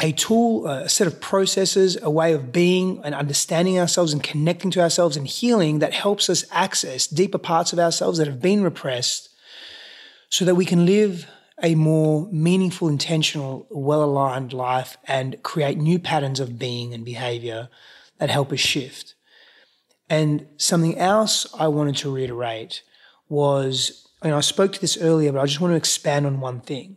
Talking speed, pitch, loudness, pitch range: 170 wpm, 155 Hz, -21 LUFS, 140-180 Hz